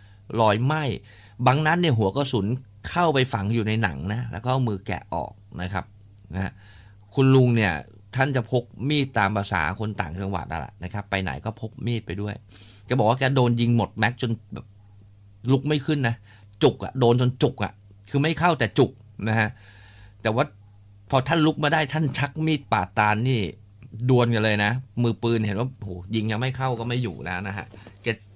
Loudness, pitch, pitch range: -24 LUFS, 110 Hz, 100-125 Hz